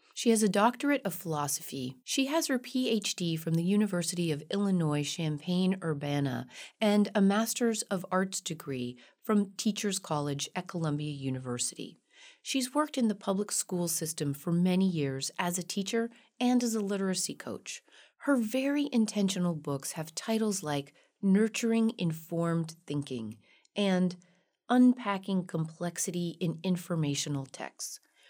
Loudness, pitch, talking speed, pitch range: -31 LUFS, 185 Hz, 135 wpm, 155-215 Hz